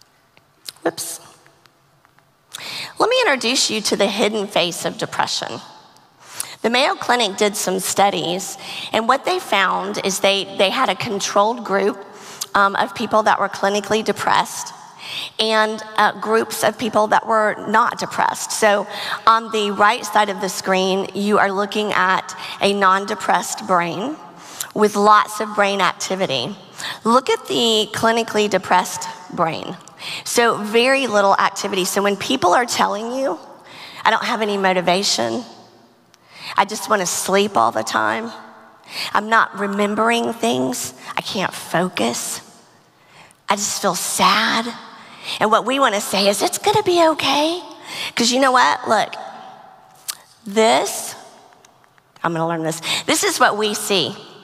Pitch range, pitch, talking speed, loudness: 195-225 Hz, 205 Hz, 145 wpm, -18 LUFS